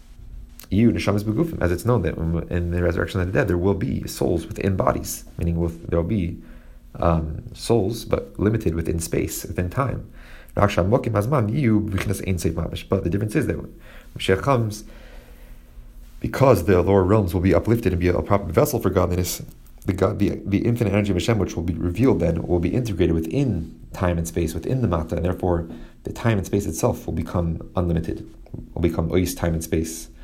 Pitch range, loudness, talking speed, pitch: 85-105 Hz, -22 LUFS, 175 wpm, 90 Hz